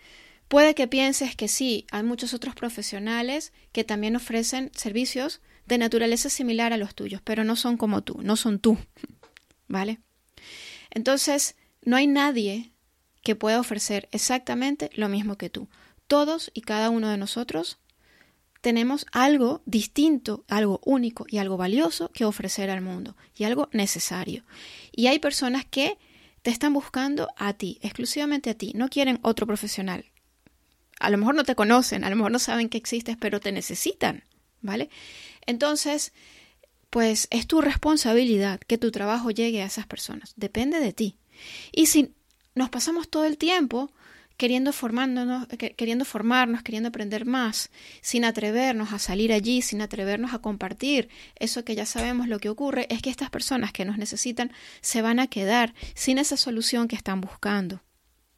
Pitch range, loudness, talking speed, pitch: 215-265 Hz, -25 LUFS, 160 wpm, 235 Hz